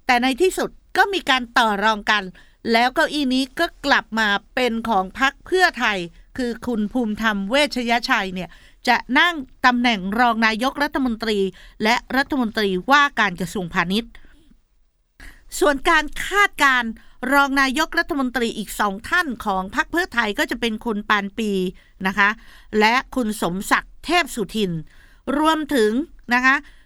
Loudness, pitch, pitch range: -20 LUFS, 245 Hz, 215-280 Hz